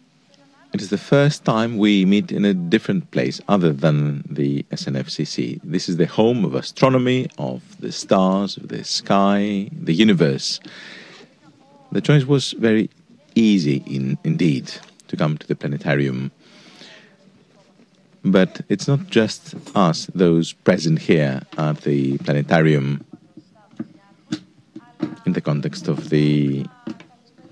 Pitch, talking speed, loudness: 100 Hz, 125 wpm, -19 LUFS